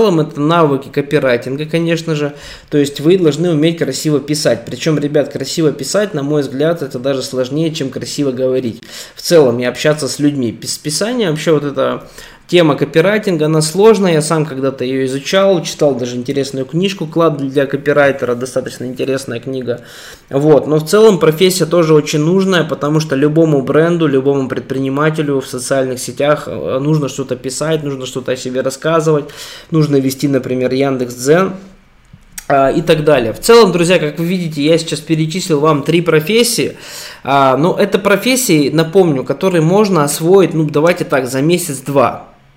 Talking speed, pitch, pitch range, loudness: 160 wpm, 150 Hz, 135-165 Hz, -13 LUFS